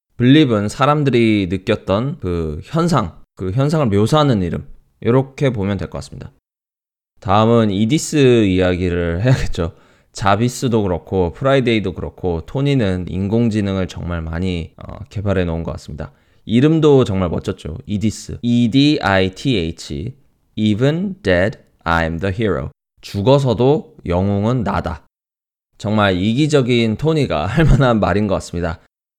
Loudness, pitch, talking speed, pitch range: -17 LUFS, 100 Hz, 305 characters per minute, 90-125 Hz